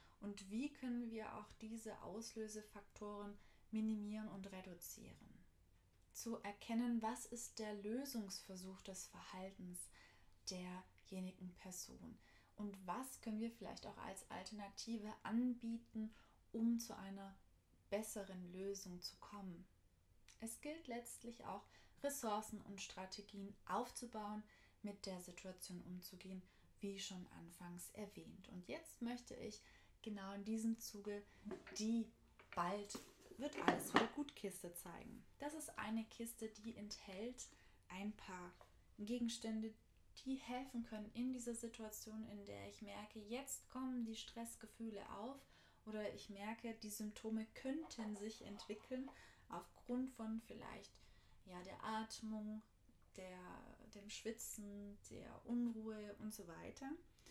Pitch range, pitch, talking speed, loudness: 195-230 Hz, 215 Hz, 120 wpm, -49 LUFS